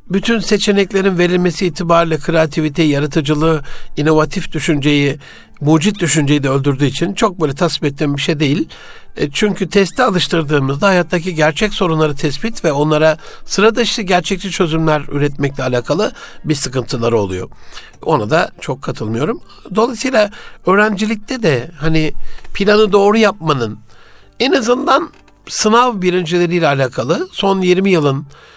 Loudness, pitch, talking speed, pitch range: -14 LUFS, 170 Hz, 120 wpm, 150-200 Hz